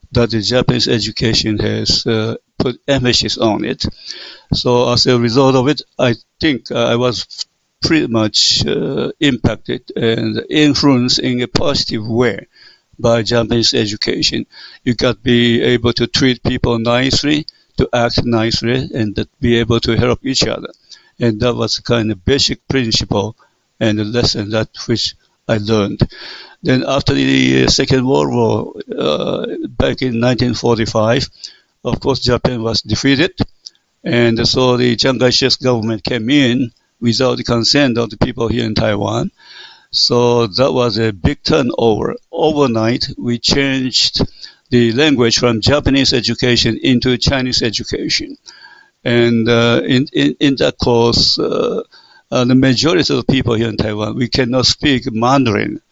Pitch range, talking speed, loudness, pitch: 115-130 Hz, 145 wpm, -14 LUFS, 120 Hz